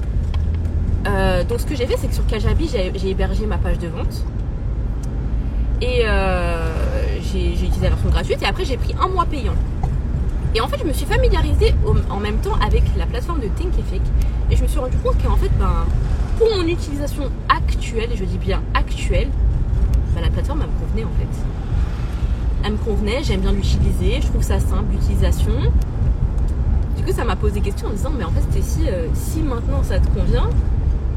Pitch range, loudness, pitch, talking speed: 70-95 Hz, -20 LUFS, 75 Hz, 205 wpm